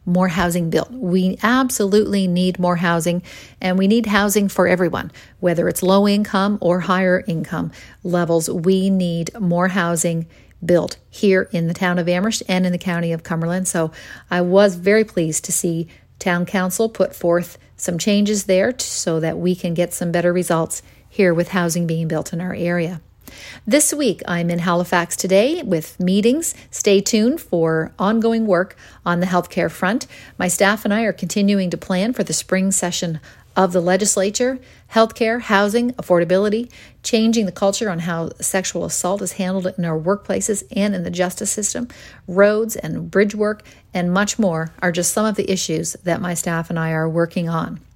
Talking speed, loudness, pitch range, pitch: 180 wpm, -19 LUFS, 175-205 Hz, 185 Hz